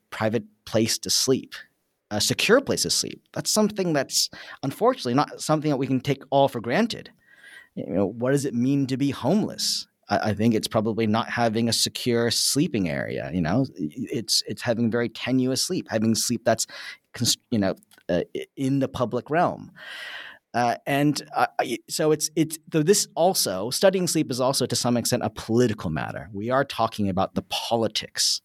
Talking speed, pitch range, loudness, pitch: 175 wpm, 115-155 Hz, -24 LUFS, 130 Hz